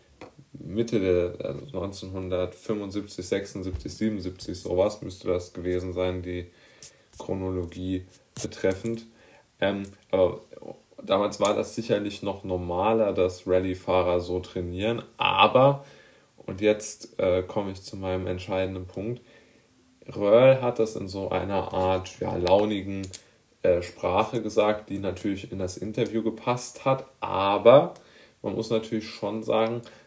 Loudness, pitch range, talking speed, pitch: -26 LUFS, 90-110 Hz, 120 wpm, 95 Hz